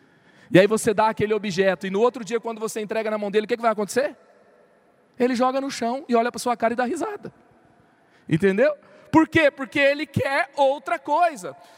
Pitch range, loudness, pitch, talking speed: 215-275 Hz, -22 LUFS, 235 Hz, 210 wpm